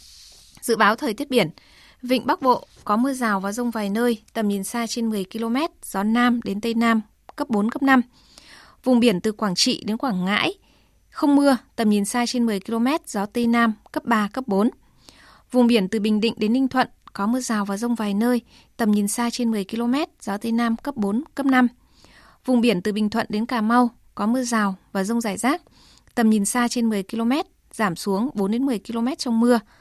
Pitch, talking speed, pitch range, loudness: 230 Hz, 215 wpm, 210-245 Hz, -22 LUFS